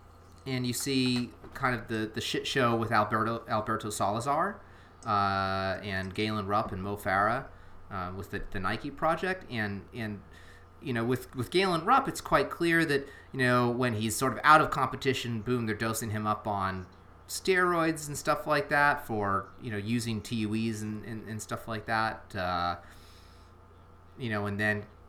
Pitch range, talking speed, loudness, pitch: 95-125 Hz, 175 wpm, -30 LUFS, 110 Hz